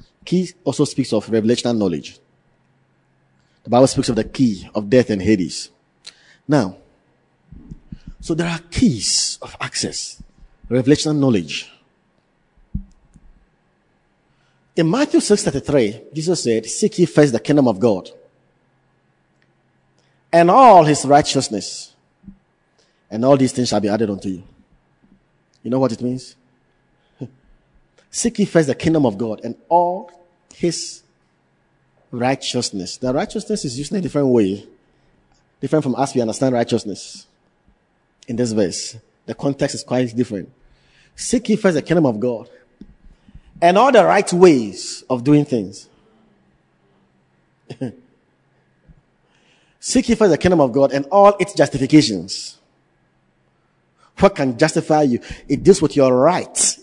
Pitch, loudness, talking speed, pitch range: 135 Hz, -17 LUFS, 125 wpm, 115-170 Hz